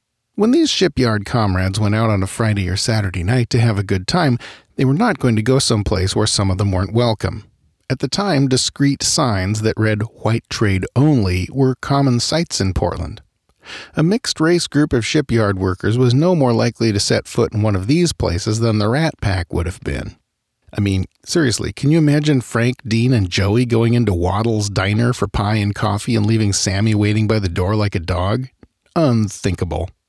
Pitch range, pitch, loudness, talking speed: 100-130 Hz, 110 Hz, -17 LUFS, 200 wpm